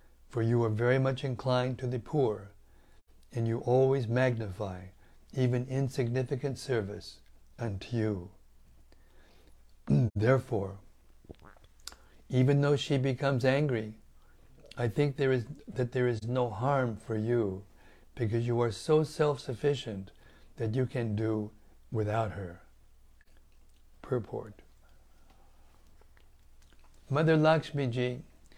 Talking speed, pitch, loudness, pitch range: 105 wpm, 115 Hz, -31 LUFS, 95-130 Hz